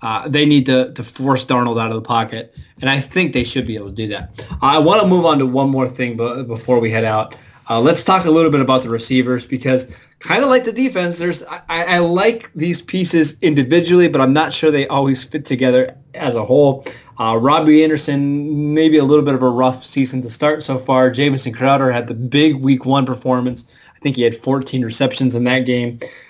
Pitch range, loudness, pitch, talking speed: 125-155 Hz, -15 LUFS, 135 Hz, 230 wpm